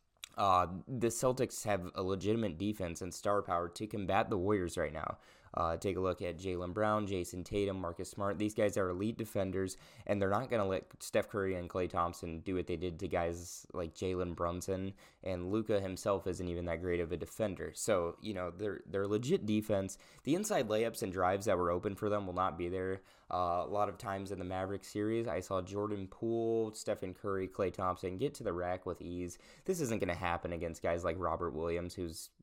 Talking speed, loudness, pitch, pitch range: 215 wpm, -37 LUFS, 95 Hz, 90-105 Hz